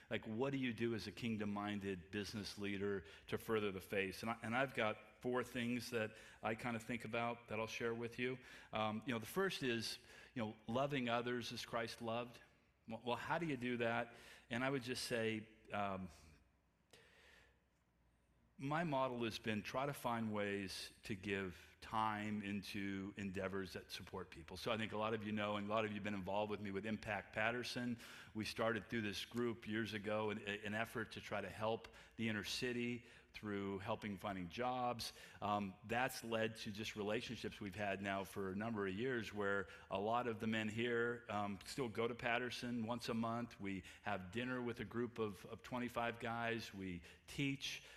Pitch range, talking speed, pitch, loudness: 100-120 Hz, 195 wpm, 110 Hz, -44 LUFS